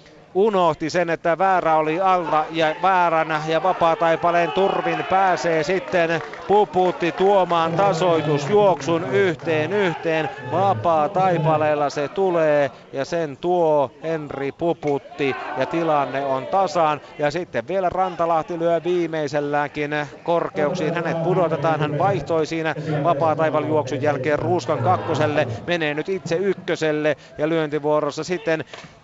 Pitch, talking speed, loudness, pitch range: 160 Hz, 110 wpm, -21 LUFS, 150-175 Hz